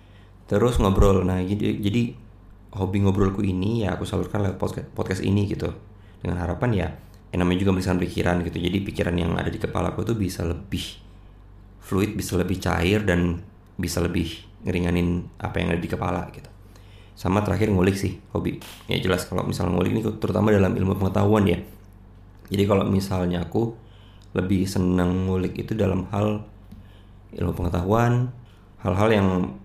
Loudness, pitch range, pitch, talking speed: -24 LUFS, 90-105 Hz, 95 Hz, 160 wpm